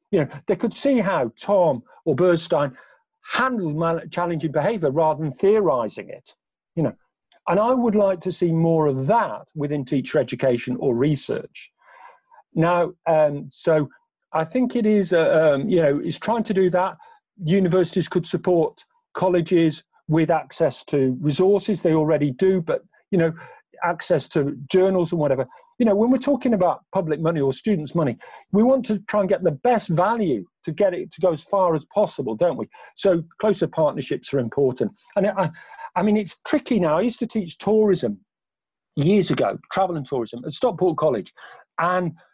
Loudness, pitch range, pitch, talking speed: -22 LUFS, 155-210 Hz, 180 Hz, 175 wpm